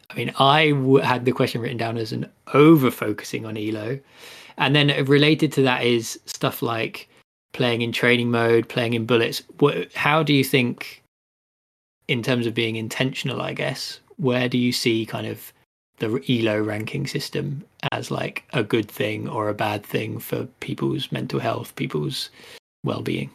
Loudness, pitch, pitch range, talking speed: -22 LUFS, 125 Hz, 115-140 Hz, 175 wpm